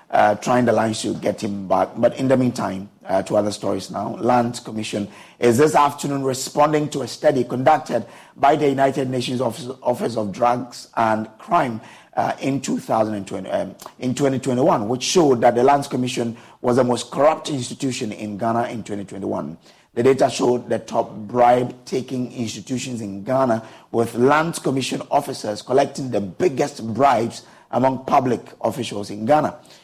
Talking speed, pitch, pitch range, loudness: 165 wpm, 125 Hz, 110-135 Hz, -21 LUFS